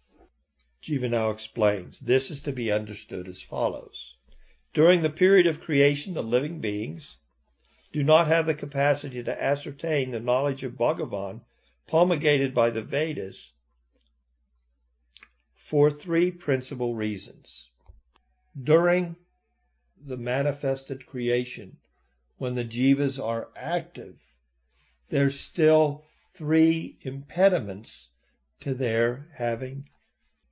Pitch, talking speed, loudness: 125 Hz, 105 wpm, -26 LUFS